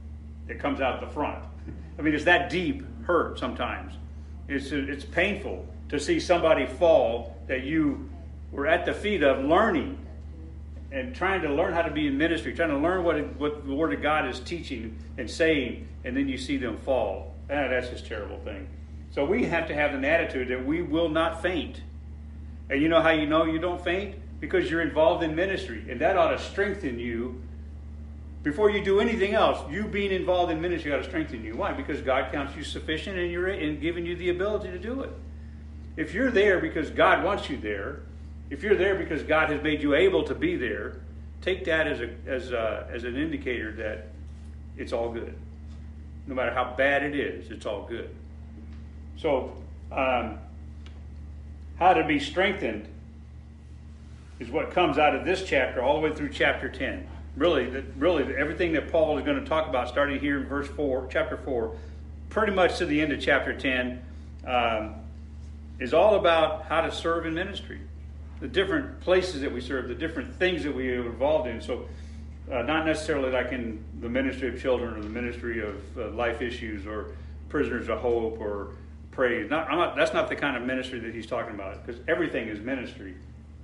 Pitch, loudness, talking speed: 75 Hz, -27 LUFS, 195 wpm